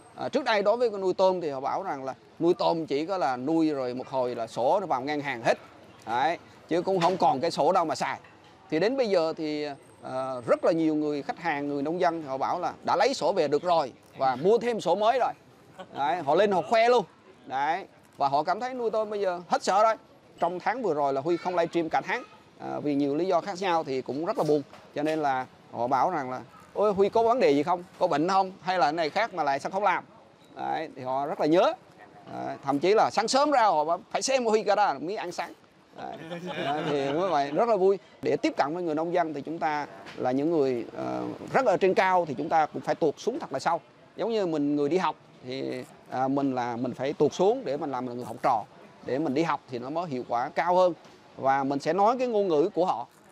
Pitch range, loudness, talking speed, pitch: 140-190 Hz, -27 LUFS, 265 wpm, 160 Hz